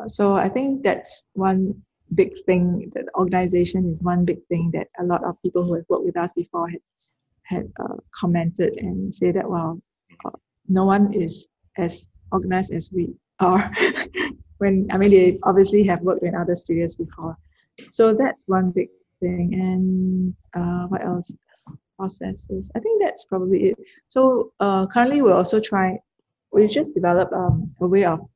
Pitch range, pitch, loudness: 175-195 Hz, 185 Hz, -21 LUFS